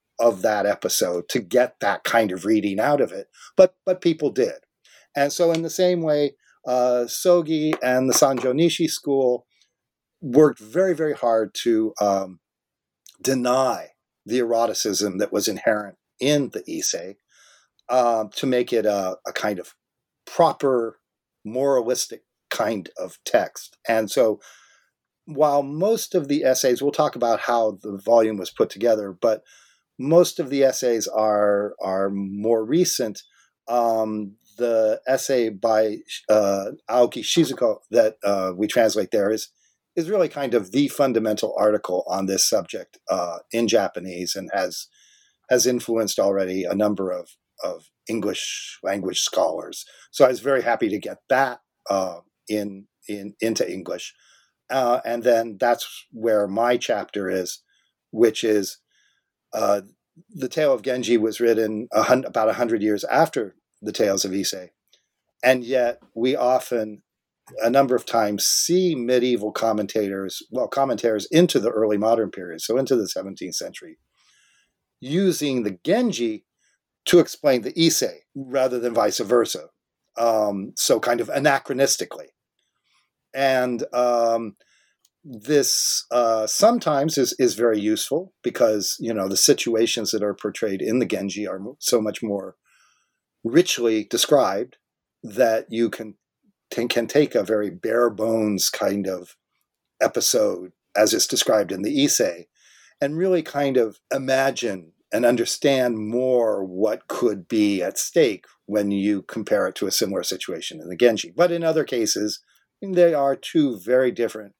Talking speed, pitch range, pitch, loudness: 145 wpm, 105-140 Hz, 120 Hz, -22 LUFS